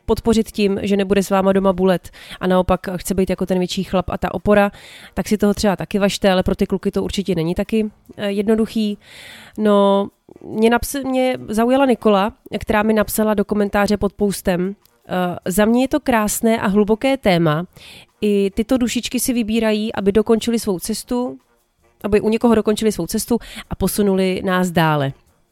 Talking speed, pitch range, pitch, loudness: 175 wpm, 190-220 Hz, 205 Hz, -18 LUFS